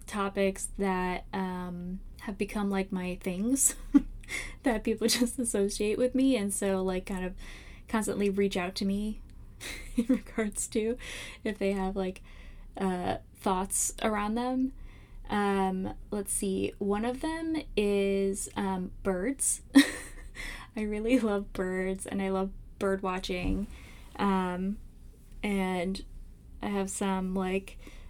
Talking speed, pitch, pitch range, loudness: 125 wpm, 200 Hz, 190-220 Hz, -31 LUFS